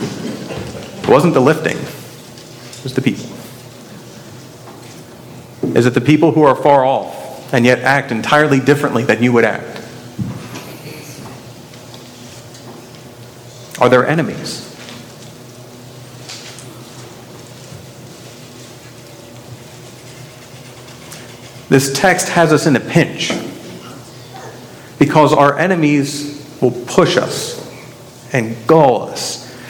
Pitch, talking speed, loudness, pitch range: 125 Hz, 90 wpm, -14 LUFS, 120-135 Hz